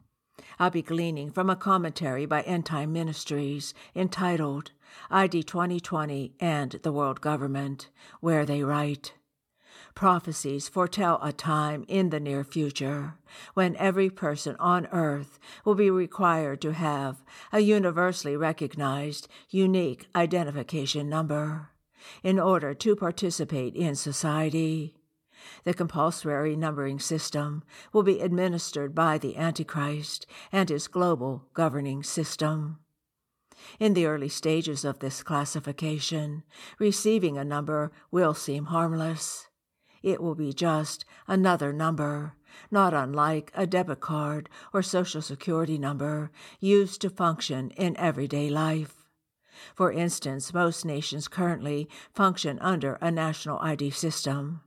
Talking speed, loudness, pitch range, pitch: 120 wpm, -28 LUFS, 145-175 Hz, 155 Hz